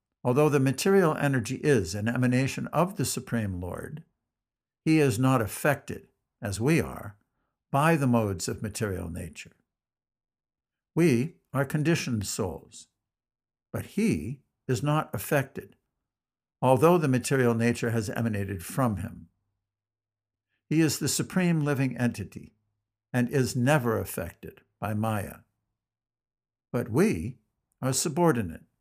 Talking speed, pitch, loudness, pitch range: 120 wpm, 120 Hz, -27 LUFS, 105-140 Hz